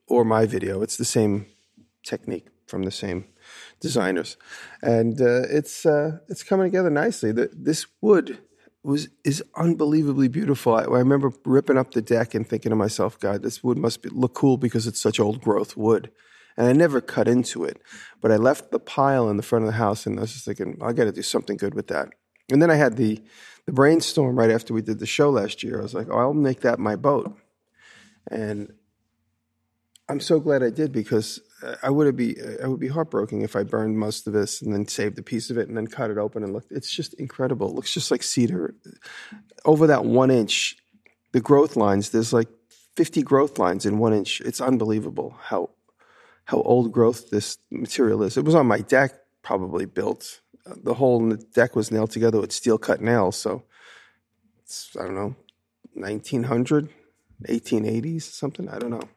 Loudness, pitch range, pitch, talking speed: -23 LUFS, 110-140 Hz, 115 Hz, 200 wpm